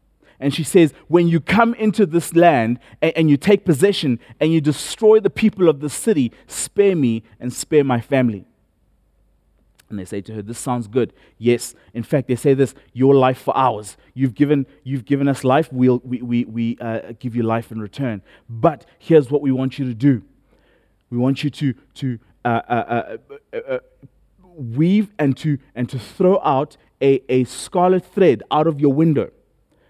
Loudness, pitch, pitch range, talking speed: -18 LUFS, 135 Hz, 120-160 Hz, 190 wpm